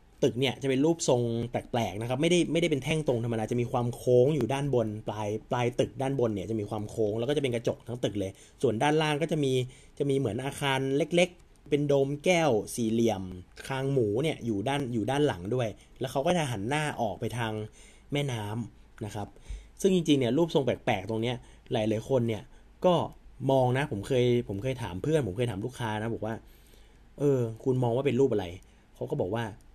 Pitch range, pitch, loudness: 110-140 Hz, 125 Hz, -29 LUFS